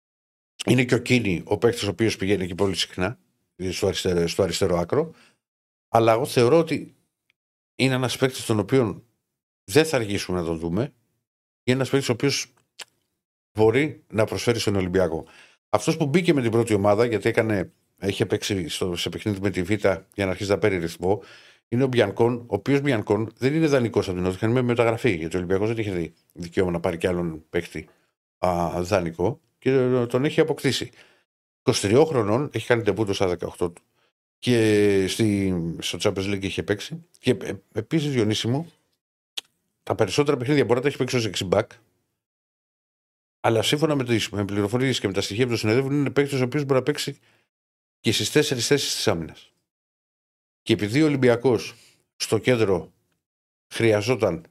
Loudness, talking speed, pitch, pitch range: -23 LUFS, 175 wpm, 115 Hz, 95-130 Hz